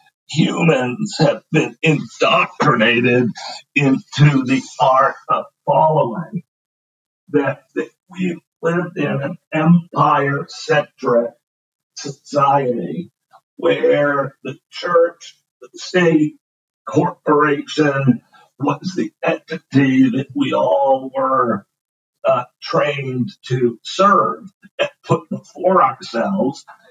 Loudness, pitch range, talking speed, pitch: -17 LUFS, 135-180 Hz, 85 wpm, 150 Hz